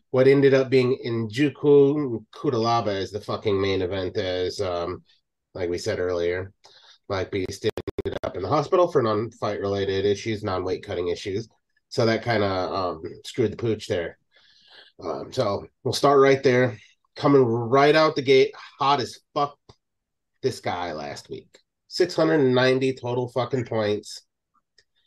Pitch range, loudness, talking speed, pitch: 105-140 Hz, -23 LUFS, 160 wpm, 125 Hz